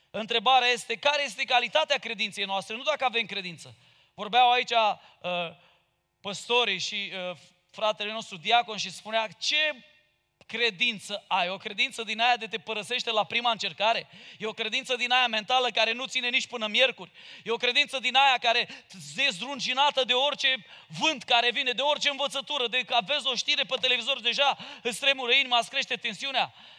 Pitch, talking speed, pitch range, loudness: 240 Hz, 175 wpm, 215-260 Hz, -26 LUFS